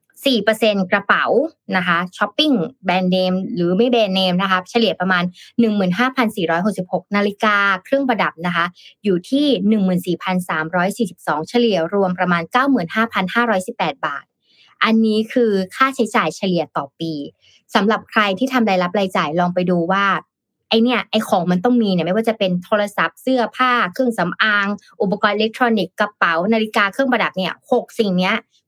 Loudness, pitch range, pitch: -18 LUFS, 180-230 Hz, 205 Hz